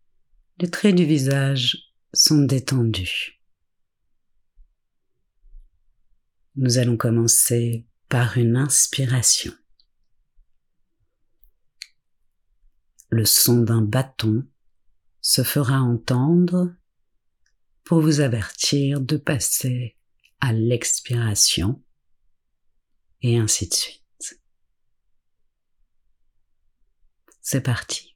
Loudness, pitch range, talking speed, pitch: -20 LUFS, 90-135 Hz, 70 wpm, 120 Hz